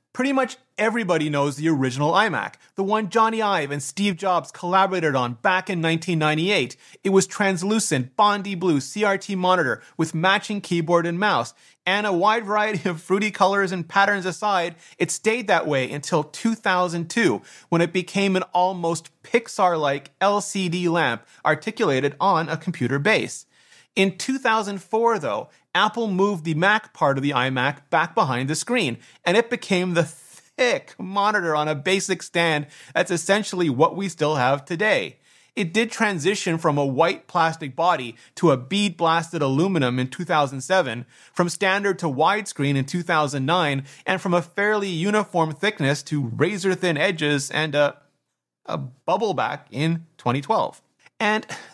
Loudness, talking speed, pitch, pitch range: -22 LUFS, 150 wpm, 180 Hz, 155-200 Hz